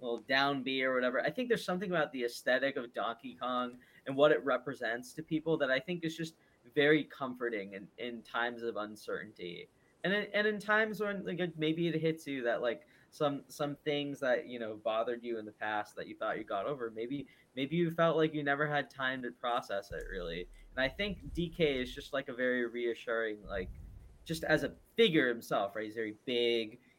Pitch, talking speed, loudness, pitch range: 130 Hz, 215 wpm, -34 LUFS, 120-155 Hz